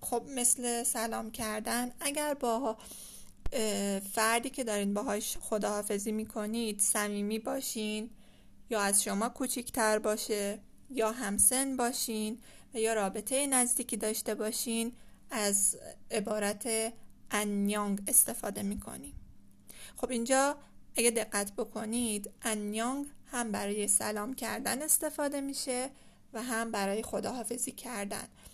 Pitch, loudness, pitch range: 225 Hz, -32 LUFS, 210-245 Hz